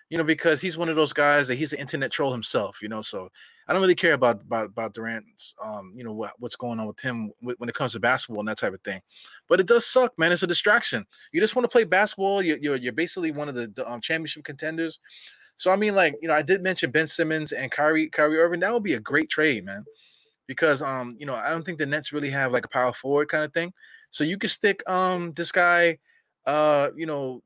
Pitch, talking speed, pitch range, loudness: 155 Hz, 260 wpm, 130-180 Hz, -24 LUFS